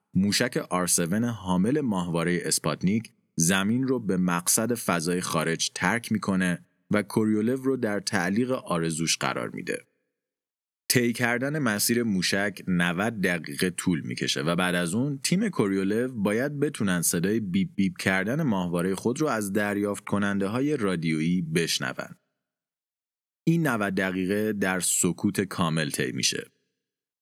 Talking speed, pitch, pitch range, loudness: 130 wpm, 100 Hz, 90-120 Hz, -26 LUFS